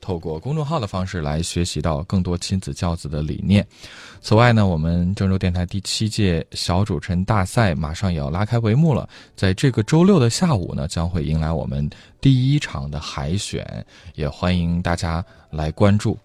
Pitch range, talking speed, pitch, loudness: 85-110 Hz, 285 characters per minute, 95 Hz, -21 LUFS